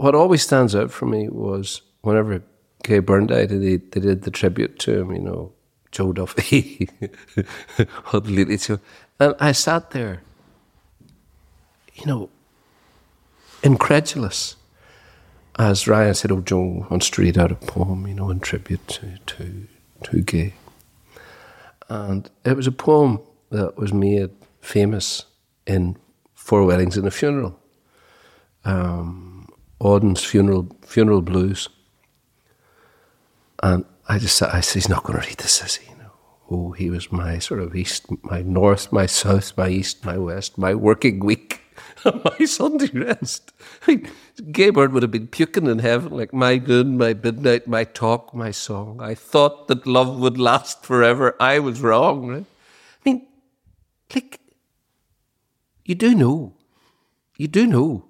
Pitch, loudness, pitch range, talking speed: 105 Hz, -20 LUFS, 95-125 Hz, 145 wpm